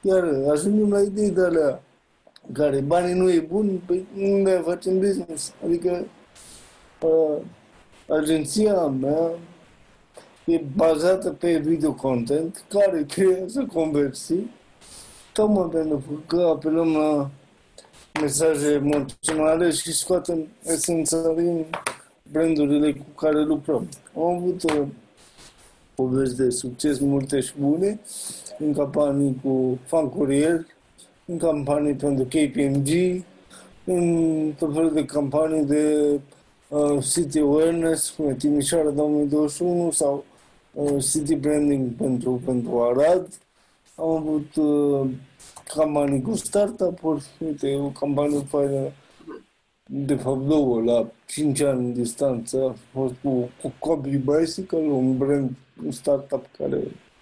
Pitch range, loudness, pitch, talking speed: 140-170 Hz, -23 LUFS, 150 Hz, 115 wpm